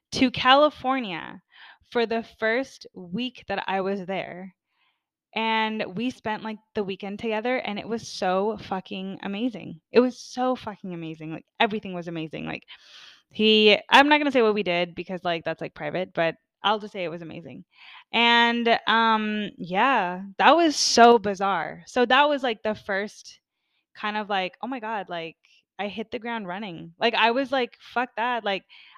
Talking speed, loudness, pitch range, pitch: 180 wpm, -24 LUFS, 190-235 Hz, 215 Hz